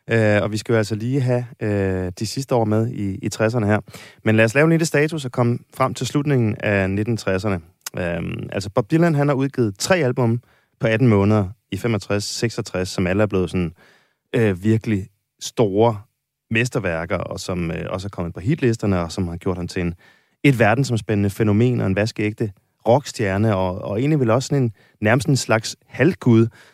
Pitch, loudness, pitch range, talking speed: 110 Hz, -20 LUFS, 100-125 Hz, 195 wpm